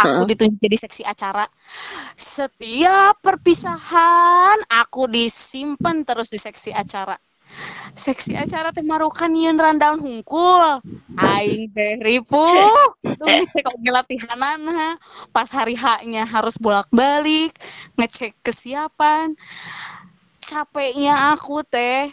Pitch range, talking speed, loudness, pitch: 230-315 Hz, 80 wpm, -18 LUFS, 275 Hz